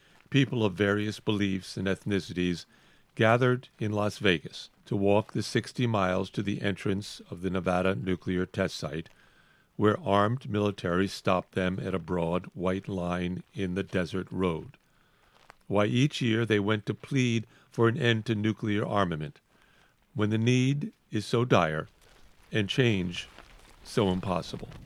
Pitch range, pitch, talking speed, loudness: 95-110 Hz, 100 Hz, 145 wpm, -29 LUFS